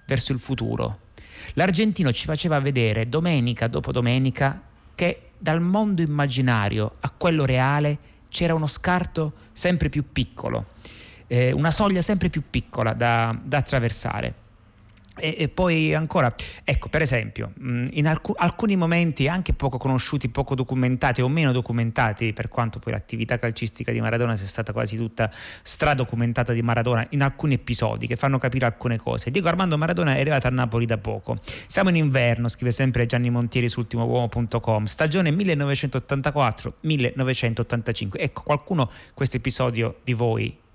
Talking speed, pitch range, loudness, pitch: 145 wpm, 115-150 Hz, -23 LUFS, 125 Hz